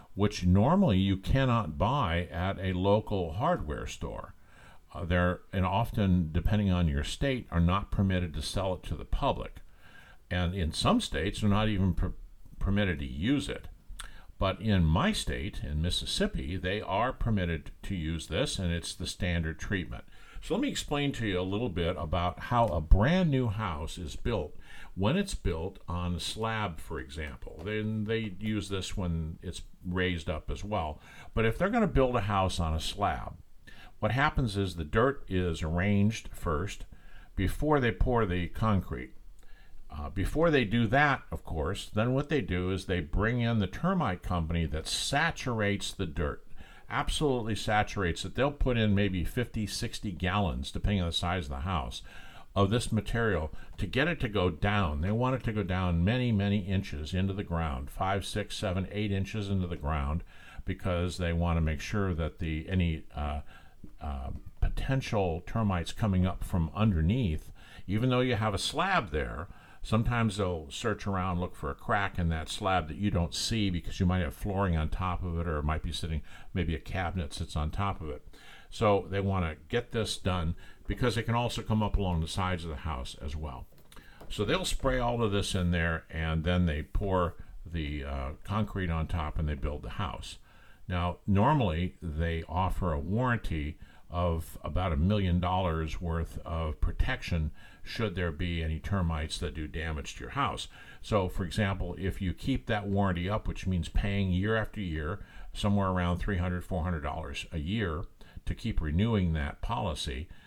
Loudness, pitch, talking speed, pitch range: -31 LUFS, 90 Hz, 185 wpm, 85-105 Hz